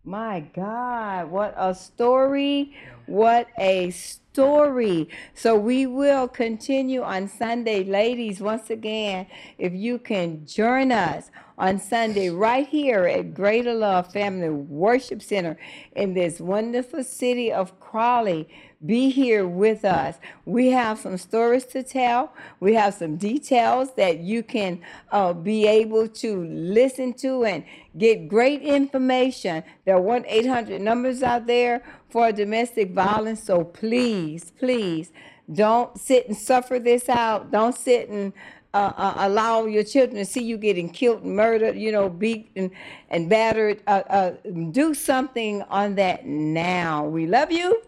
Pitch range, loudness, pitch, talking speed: 195-245 Hz, -22 LUFS, 220 Hz, 140 wpm